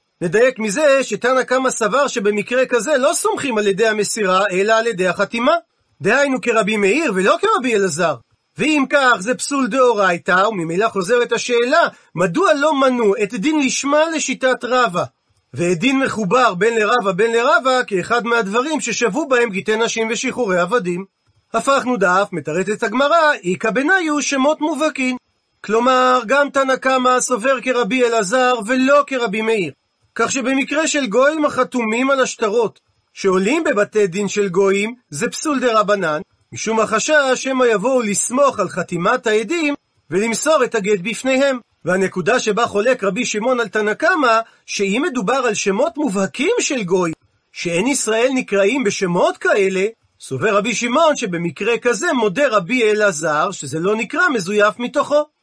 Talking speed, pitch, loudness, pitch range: 145 wpm, 235 Hz, -17 LUFS, 205-265 Hz